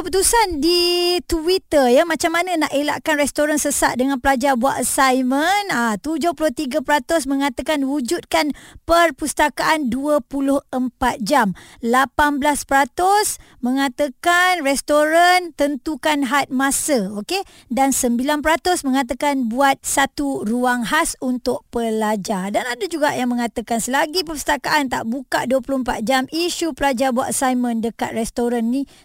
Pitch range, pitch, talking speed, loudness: 260-315 Hz, 285 Hz, 115 wpm, -19 LUFS